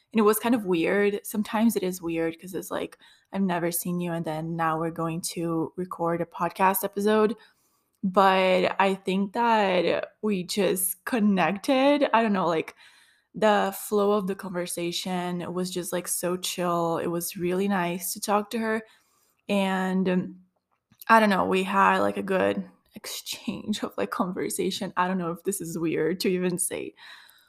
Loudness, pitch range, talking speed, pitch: -26 LUFS, 170-210 Hz, 175 wpm, 185 Hz